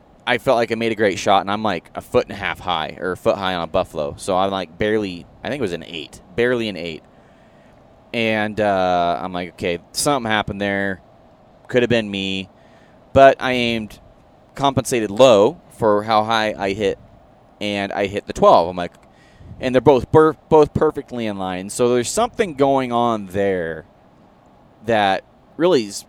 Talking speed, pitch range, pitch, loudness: 190 wpm, 95-125 Hz, 105 Hz, -19 LUFS